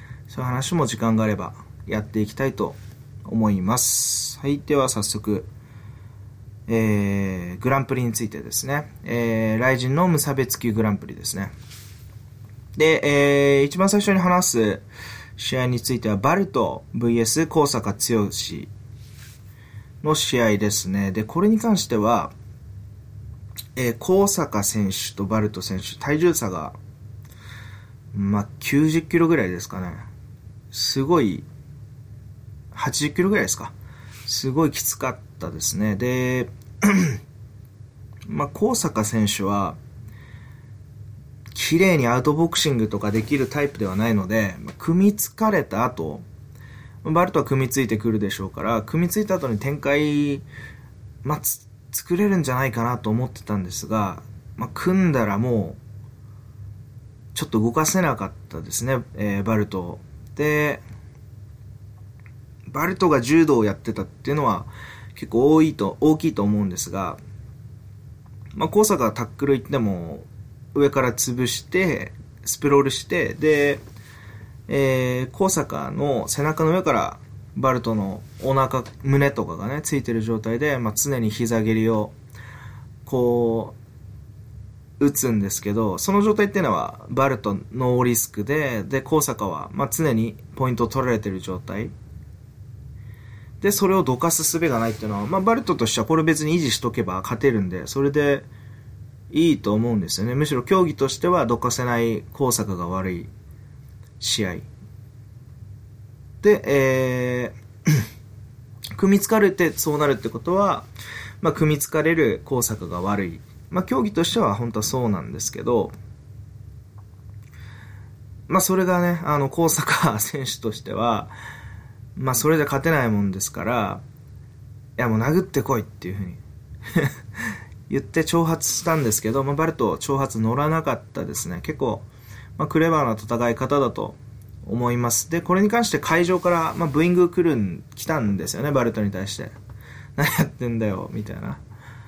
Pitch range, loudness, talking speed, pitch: 110-140 Hz, -22 LUFS, 290 characters per minute, 120 Hz